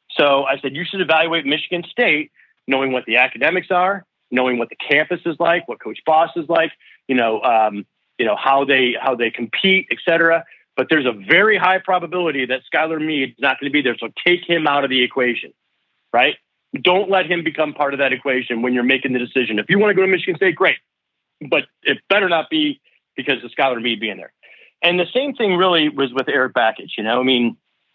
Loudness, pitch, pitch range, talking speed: -17 LUFS, 150 Hz, 130-175 Hz, 225 wpm